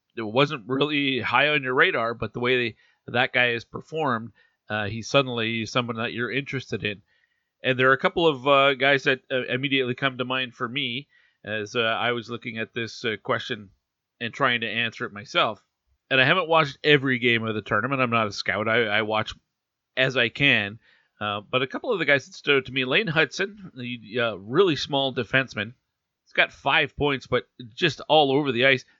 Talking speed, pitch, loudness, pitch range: 210 wpm, 125 Hz, -23 LUFS, 115-135 Hz